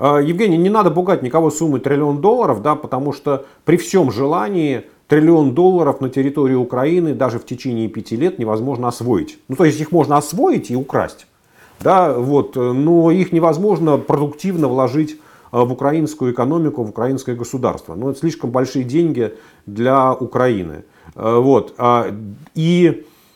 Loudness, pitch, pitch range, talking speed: -16 LUFS, 140 Hz, 125-160 Hz, 145 wpm